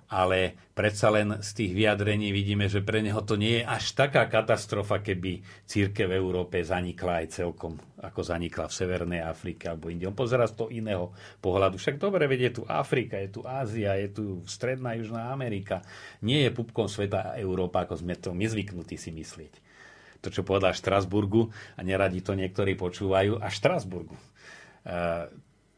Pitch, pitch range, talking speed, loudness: 100 Hz, 90-110 Hz, 170 wpm, -29 LUFS